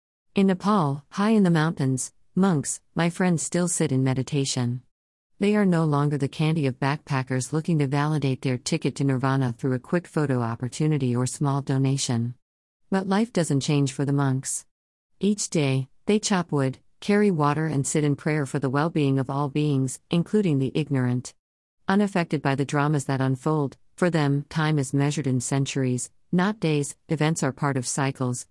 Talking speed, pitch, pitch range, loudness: 175 wpm, 145 Hz, 130-160 Hz, -24 LUFS